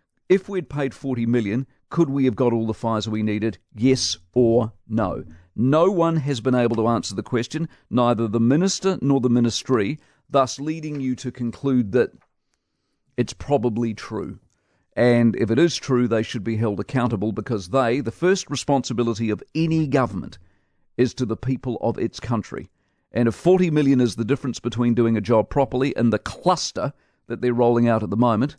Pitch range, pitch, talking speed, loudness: 115-140 Hz, 120 Hz, 185 wpm, -22 LUFS